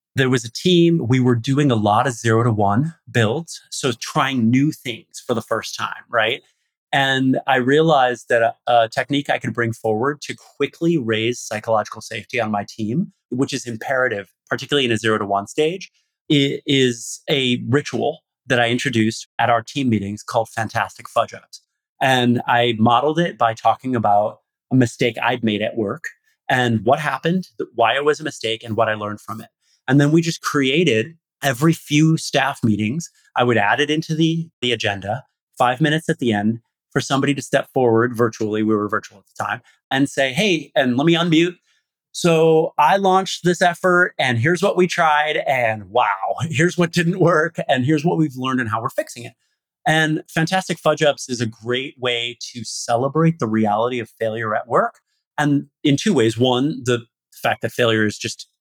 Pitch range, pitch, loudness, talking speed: 115-155 Hz, 130 Hz, -19 LUFS, 190 wpm